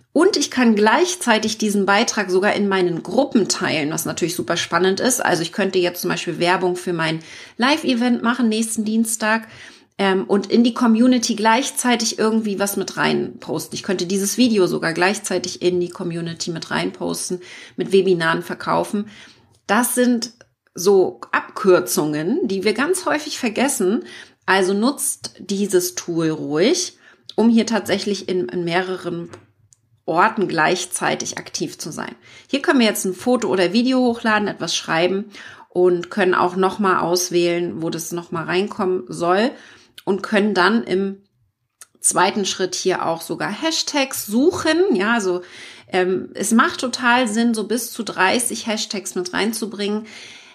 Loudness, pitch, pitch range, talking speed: -19 LUFS, 200 Hz, 180-235 Hz, 150 wpm